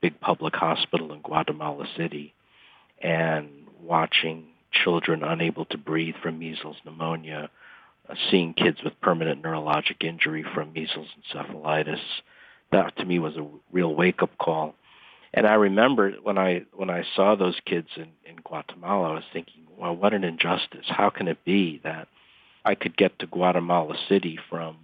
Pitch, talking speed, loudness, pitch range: 80 Hz, 155 wpm, -25 LUFS, 80-90 Hz